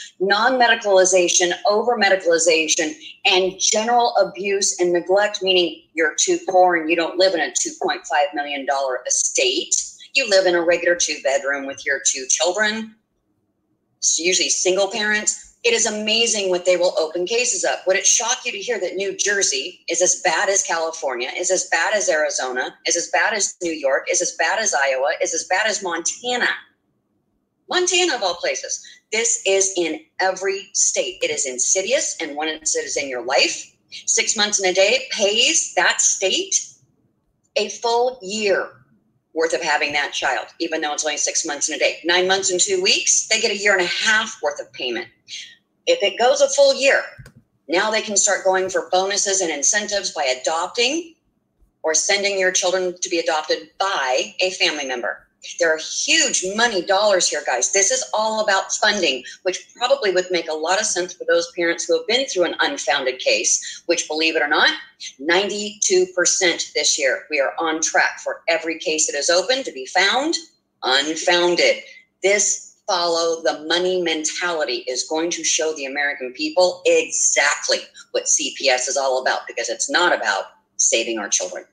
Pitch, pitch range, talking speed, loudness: 185 Hz, 170-220 Hz, 180 wpm, -19 LUFS